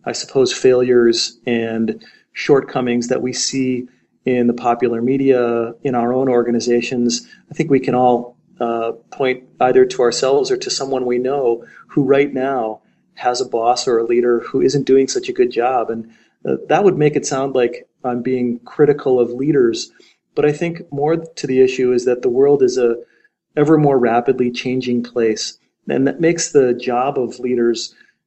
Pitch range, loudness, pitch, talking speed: 120-145 Hz, -17 LUFS, 125 Hz, 180 wpm